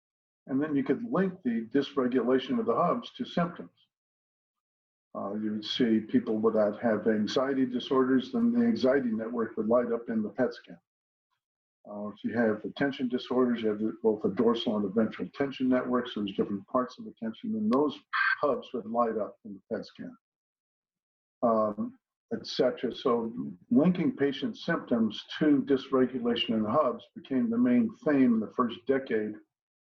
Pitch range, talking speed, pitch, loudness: 110-140 Hz, 170 wpm, 125 Hz, -29 LUFS